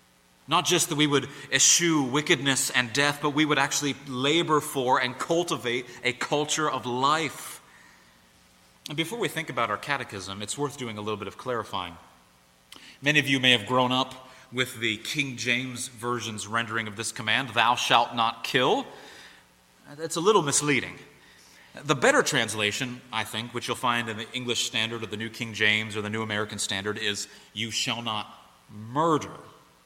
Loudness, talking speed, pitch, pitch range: -25 LUFS, 175 wpm, 120 Hz, 105-140 Hz